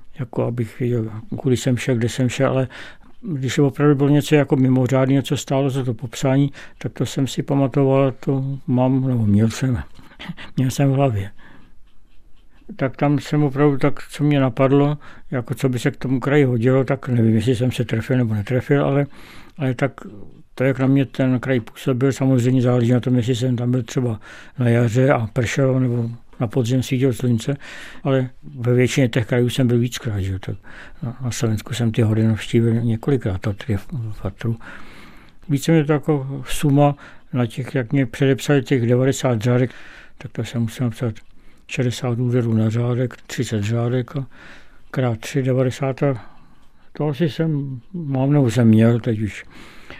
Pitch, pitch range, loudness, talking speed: 130 Hz, 120-140 Hz, -20 LUFS, 175 wpm